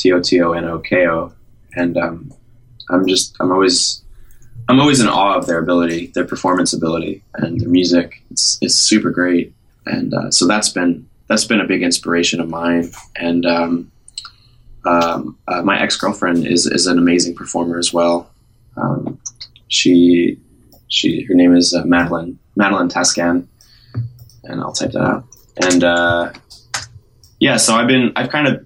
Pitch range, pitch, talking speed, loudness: 85-100 Hz, 85 Hz, 170 wpm, -15 LUFS